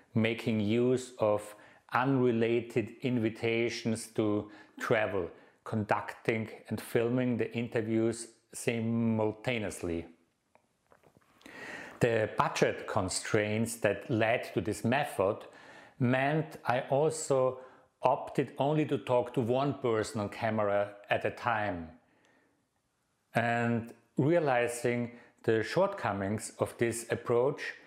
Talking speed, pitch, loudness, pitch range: 95 wpm, 115 Hz, -31 LUFS, 110-125 Hz